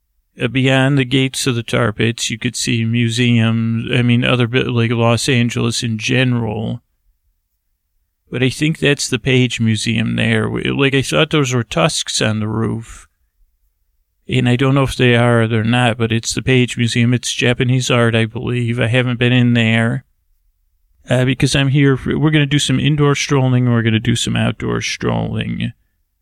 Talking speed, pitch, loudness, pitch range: 180 wpm, 120 Hz, -15 LUFS, 110-130 Hz